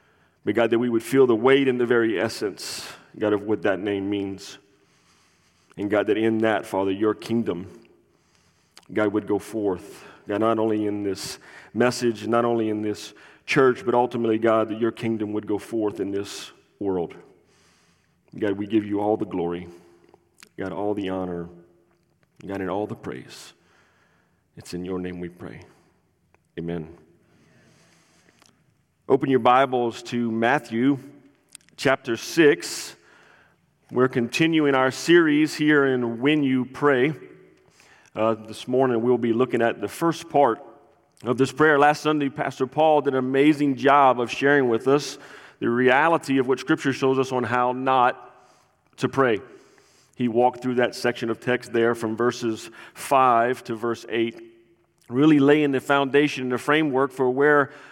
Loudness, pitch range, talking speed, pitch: -22 LUFS, 105-135 Hz, 155 wpm, 120 Hz